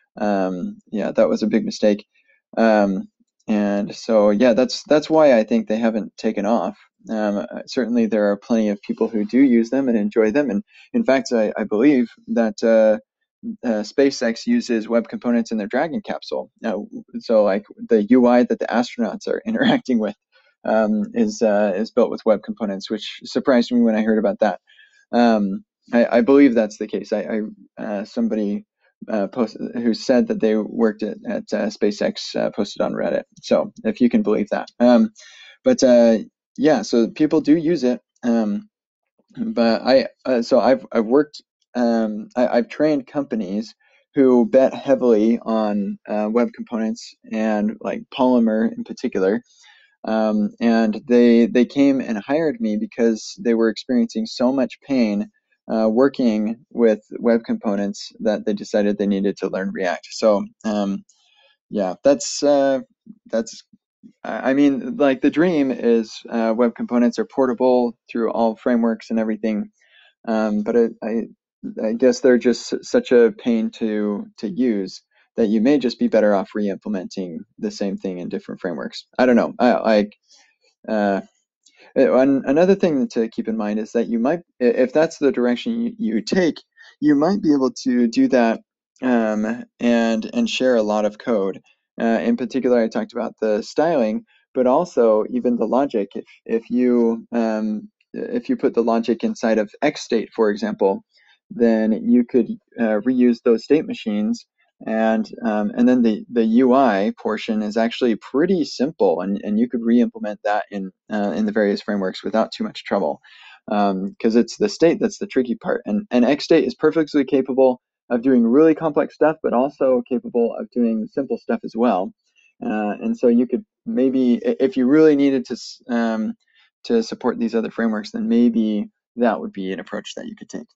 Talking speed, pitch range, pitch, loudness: 175 wpm, 110-175 Hz, 120 Hz, -20 LUFS